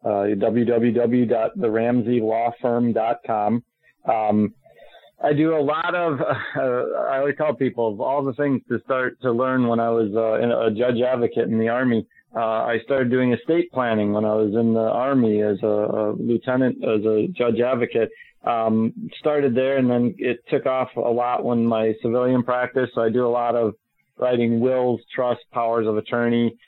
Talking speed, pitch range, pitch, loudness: 170 wpm, 115-130 Hz, 120 Hz, -21 LUFS